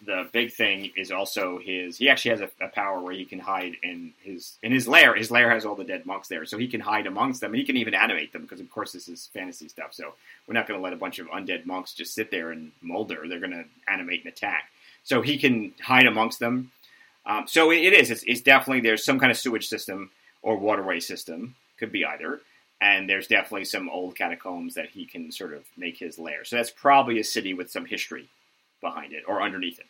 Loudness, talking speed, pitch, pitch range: -23 LUFS, 245 wpm, 115 Hz, 95-135 Hz